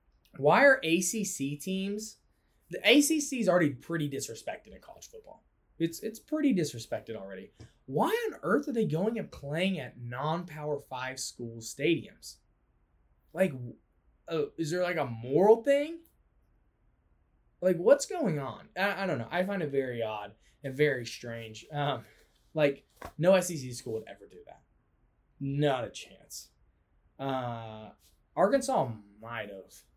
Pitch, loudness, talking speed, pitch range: 145 Hz, -30 LUFS, 140 wpm, 115-190 Hz